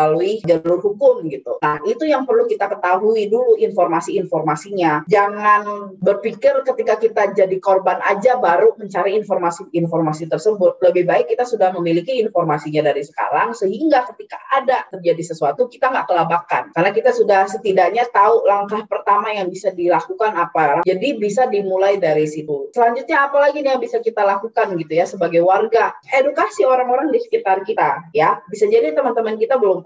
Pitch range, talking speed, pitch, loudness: 180-255 Hz, 155 wpm, 205 Hz, -17 LUFS